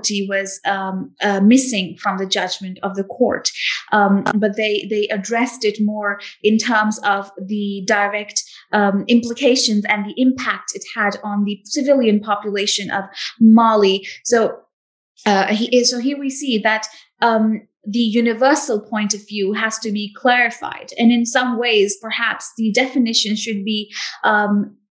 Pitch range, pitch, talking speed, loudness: 205-235 Hz, 215 Hz, 150 wpm, -18 LUFS